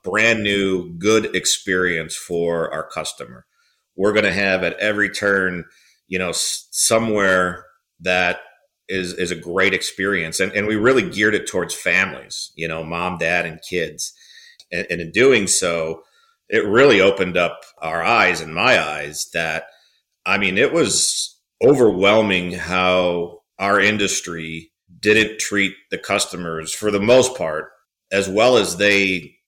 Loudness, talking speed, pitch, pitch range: -18 LUFS, 145 wpm, 95 Hz, 90-105 Hz